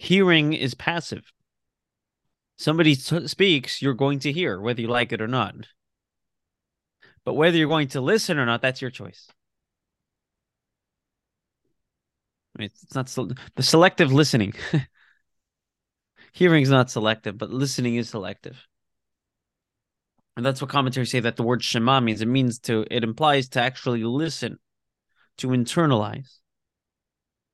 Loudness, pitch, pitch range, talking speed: -22 LUFS, 125 Hz, 115-145 Hz, 130 wpm